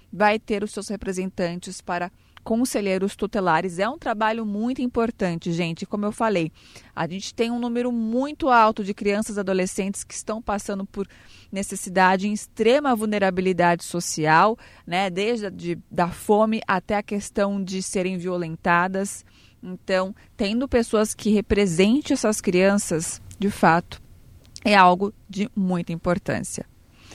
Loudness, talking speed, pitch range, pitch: -23 LUFS, 135 wpm, 185-215 Hz, 200 Hz